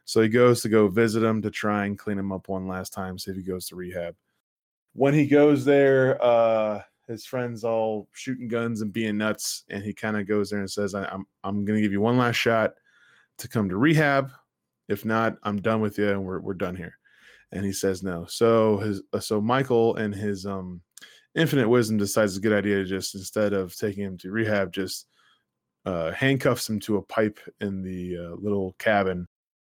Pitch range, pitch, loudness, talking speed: 95-115 Hz, 105 Hz, -25 LUFS, 215 wpm